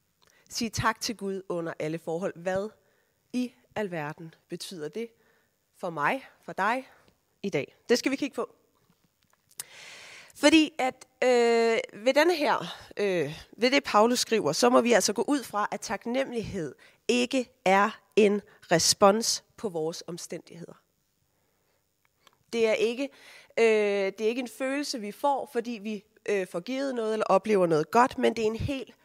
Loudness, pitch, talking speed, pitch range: -27 LUFS, 225 Hz, 155 wpm, 200-260 Hz